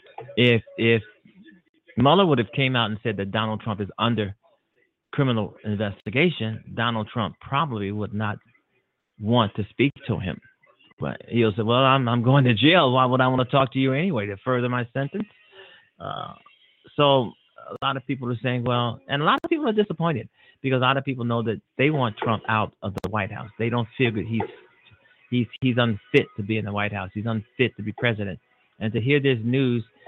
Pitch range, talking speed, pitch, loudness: 110-135 Hz, 205 wpm, 120 Hz, -23 LUFS